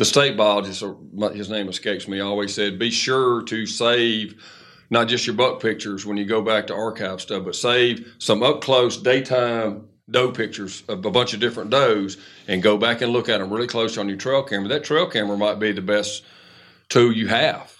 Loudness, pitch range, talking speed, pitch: -21 LUFS, 105-120 Hz, 210 wpm, 110 Hz